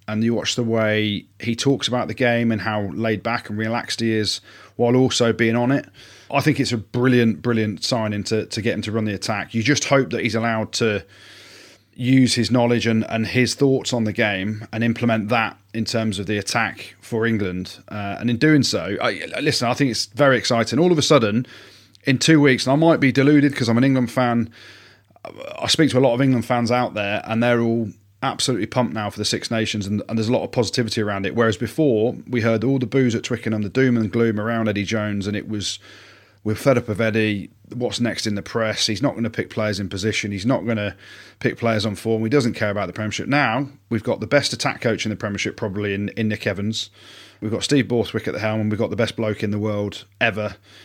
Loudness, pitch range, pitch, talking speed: -20 LUFS, 105-120 Hz, 115 Hz, 245 wpm